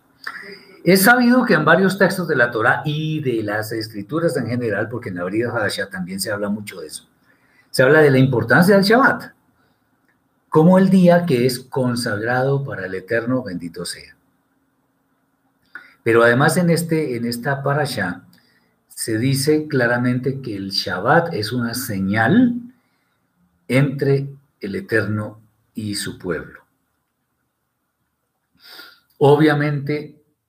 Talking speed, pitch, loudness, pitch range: 130 wpm, 135 Hz, -18 LUFS, 115-155 Hz